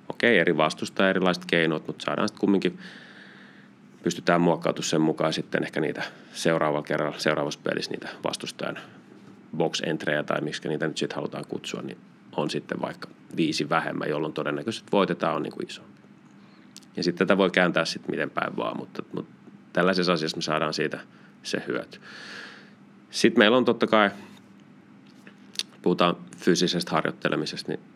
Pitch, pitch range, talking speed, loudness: 80 Hz, 75-90 Hz, 150 wpm, -26 LUFS